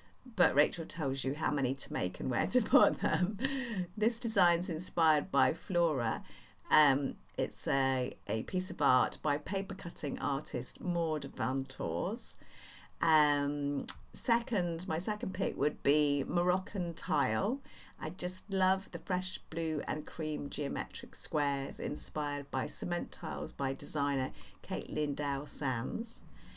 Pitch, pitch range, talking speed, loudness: 160 Hz, 145-185 Hz, 135 wpm, -33 LUFS